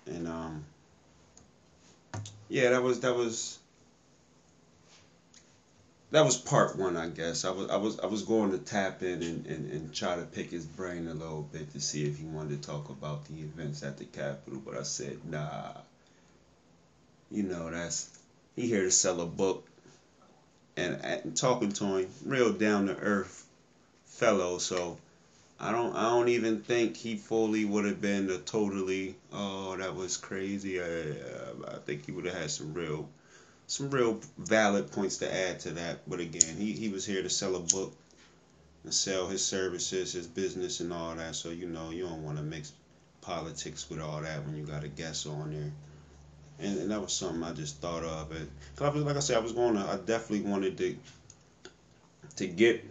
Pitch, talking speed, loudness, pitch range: 85 Hz, 190 wpm, -32 LUFS, 80-100 Hz